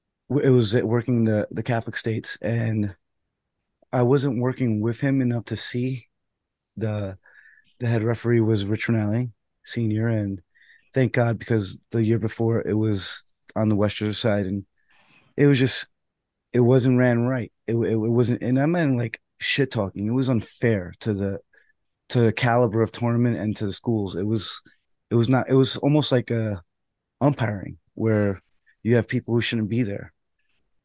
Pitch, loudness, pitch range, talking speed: 115 Hz, -23 LUFS, 105-125 Hz, 170 wpm